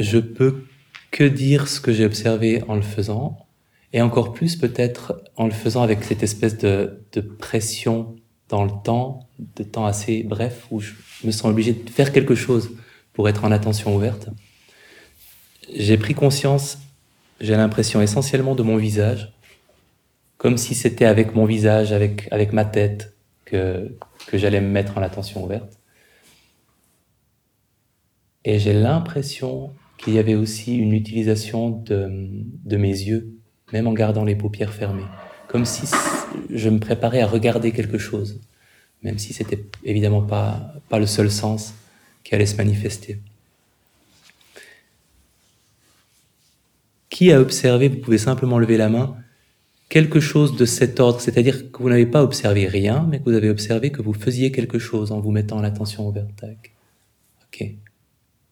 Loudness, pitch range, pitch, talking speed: -20 LUFS, 105-120 Hz, 110 Hz, 155 wpm